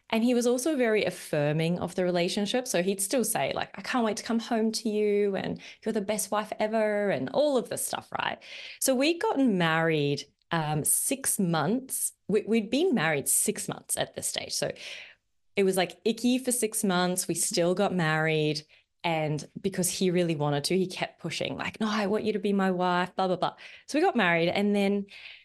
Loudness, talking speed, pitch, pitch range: -27 LUFS, 210 wpm, 200 Hz, 175-220 Hz